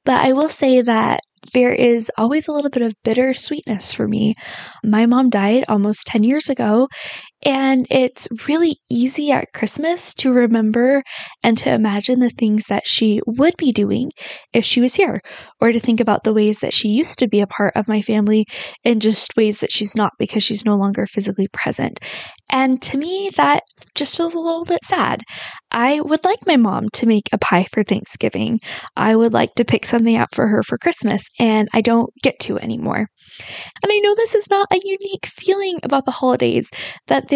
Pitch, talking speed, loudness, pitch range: 245 Hz, 200 wpm, -17 LUFS, 215-285 Hz